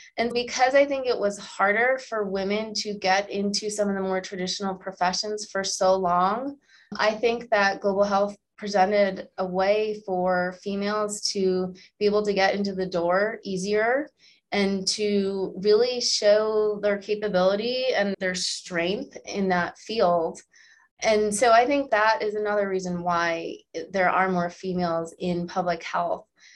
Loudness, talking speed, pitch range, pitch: -24 LUFS, 155 wpm, 185-215 Hz, 200 Hz